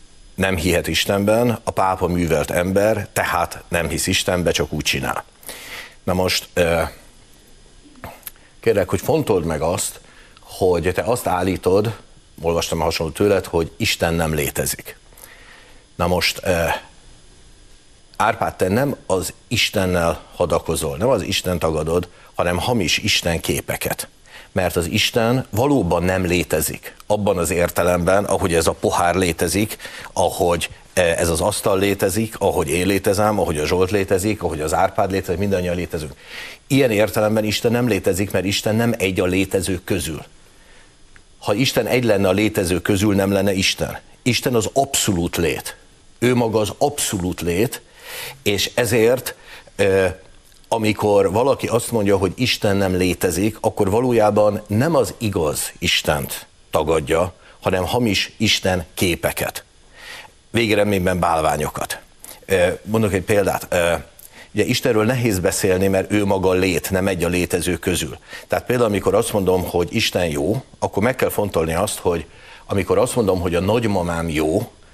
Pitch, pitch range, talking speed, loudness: 95 Hz, 90-105 Hz, 140 wpm, -19 LUFS